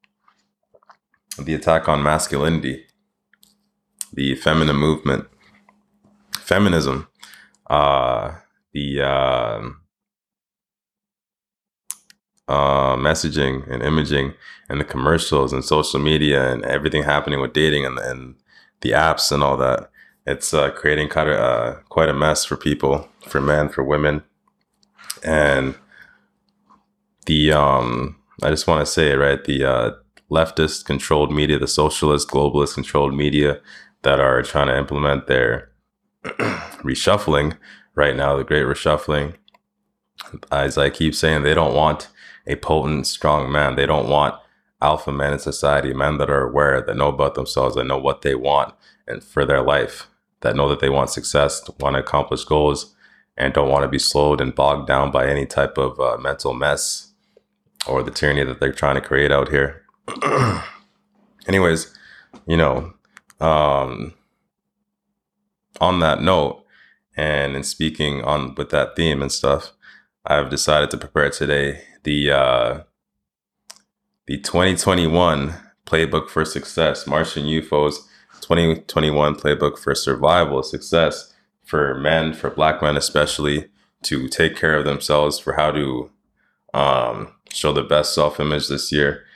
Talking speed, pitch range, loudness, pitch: 140 wpm, 70-80 Hz, -19 LUFS, 75 Hz